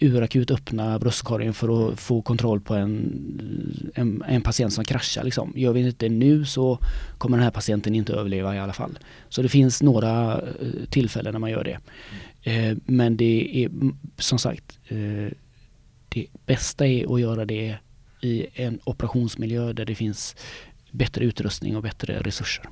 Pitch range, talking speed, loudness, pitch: 110-125 Hz, 160 wpm, -24 LUFS, 115 Hz